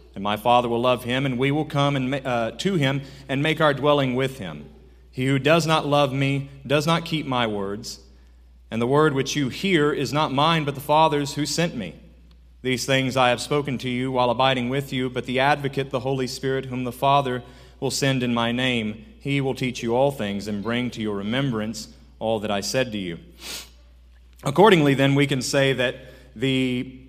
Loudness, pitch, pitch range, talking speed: -22 LUFS, 130 Hz, 115-140 Hz, 215 wpm